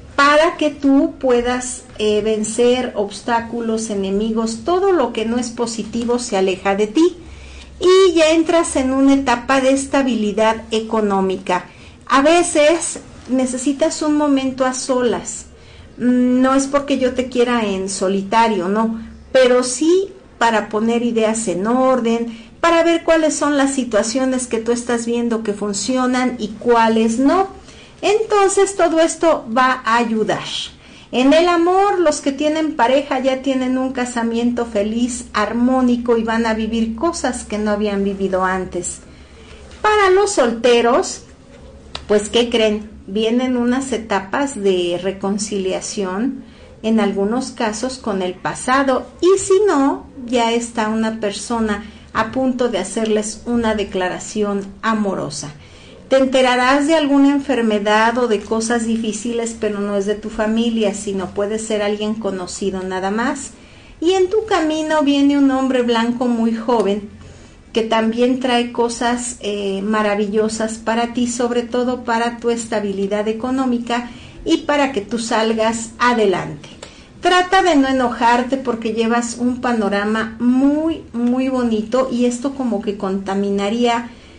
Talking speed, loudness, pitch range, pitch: 135 wpm, -17 LUFS, 215-265 Hz, 235 Hz